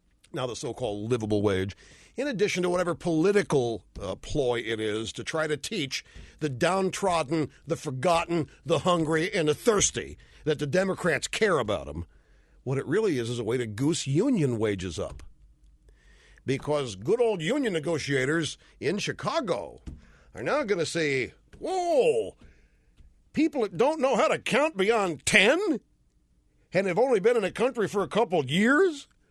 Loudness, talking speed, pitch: -27 LUFS, 165 wpm, 155 Hz